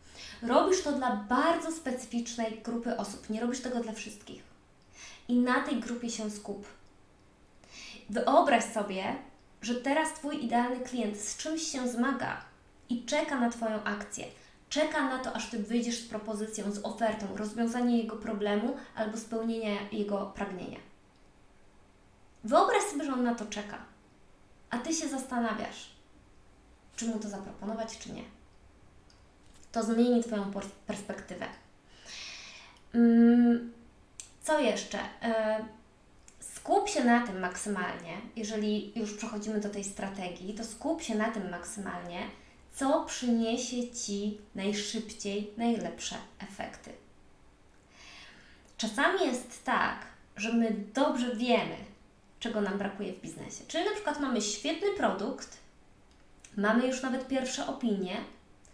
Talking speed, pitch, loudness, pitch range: 125 wpm, 230 Hz, -32 LUFS, 210-250 Hz